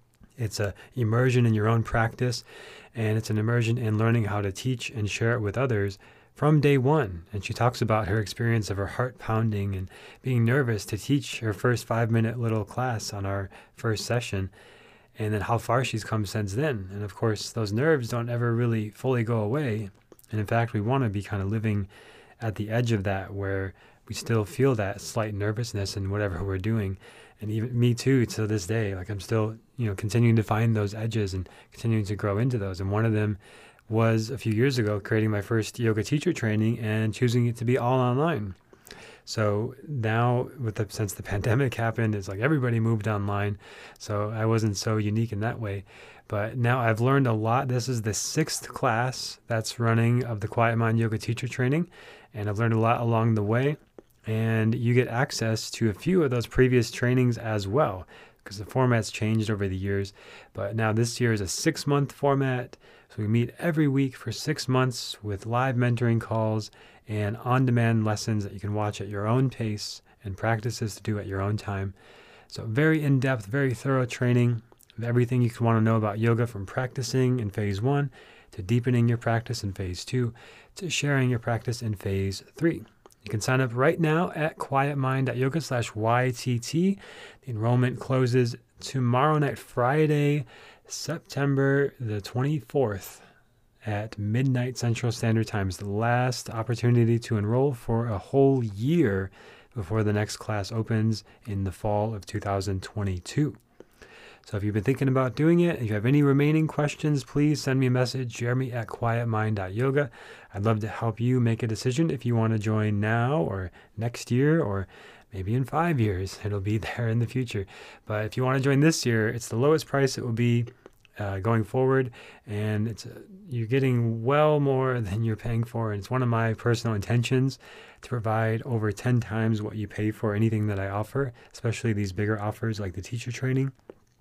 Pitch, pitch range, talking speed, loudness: 115 Hz, 105-125 Hz, 195 wpm, -27 LUFS